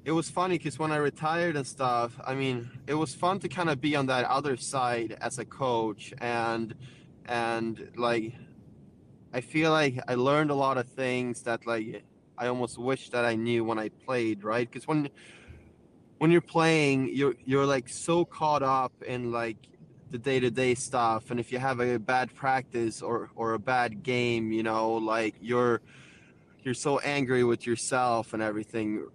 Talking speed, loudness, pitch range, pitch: 180 wpm, -29 LUFS, 115-140 Hz, 125 Hz